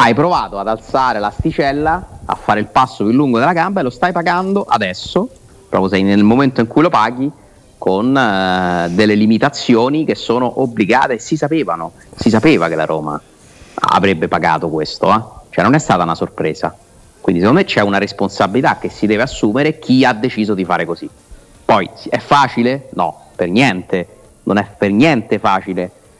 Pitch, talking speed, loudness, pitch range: 105 Hz, 175 wpm, -14 LUFS, 90-130 Hz